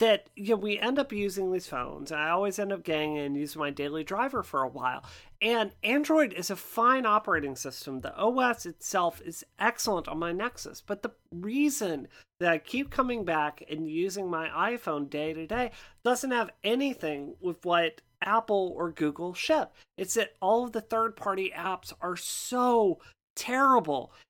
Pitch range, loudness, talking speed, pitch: 160-235 Hz, -29 LUFS, 180 wpm, 195 Hz